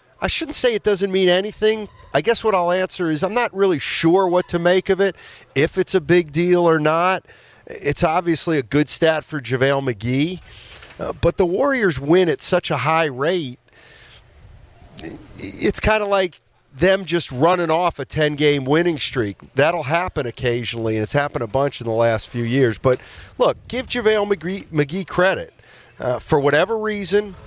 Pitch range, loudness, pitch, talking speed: 140-190 Hz, -19 LUFS, 170 Hz, 180 wpm